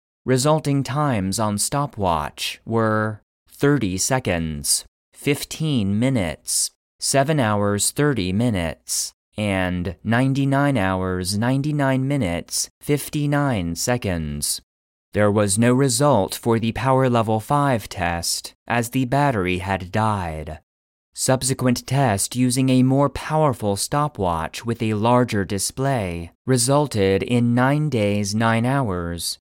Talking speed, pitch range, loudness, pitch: 105 wpm, 95-135 Hz, -21 LUFS, 115 Hz